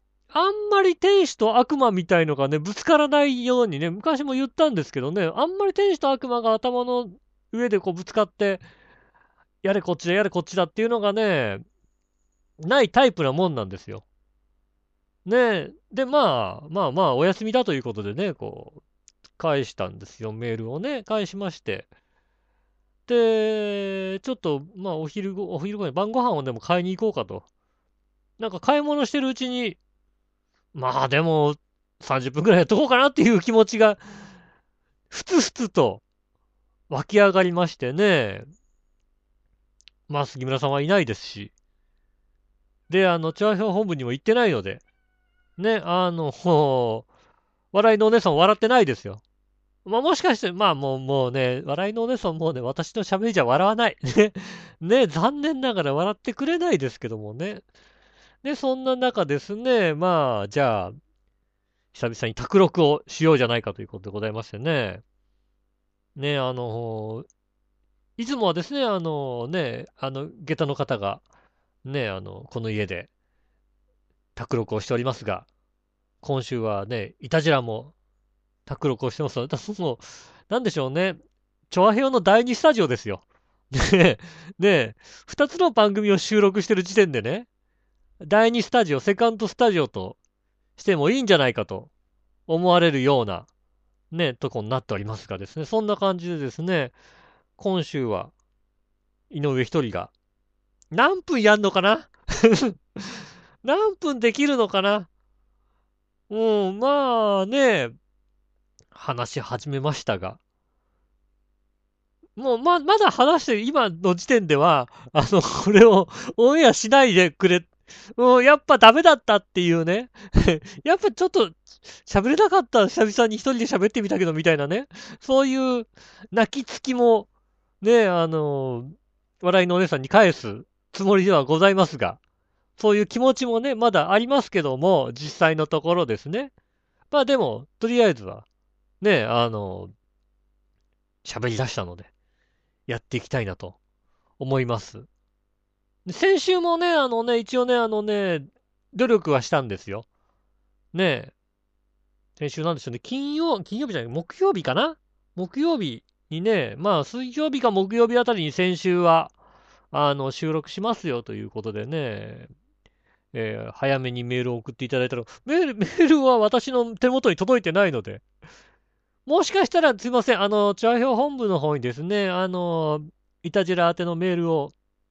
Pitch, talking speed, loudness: 180 Hz, 295 characters per minute, -22 LUFS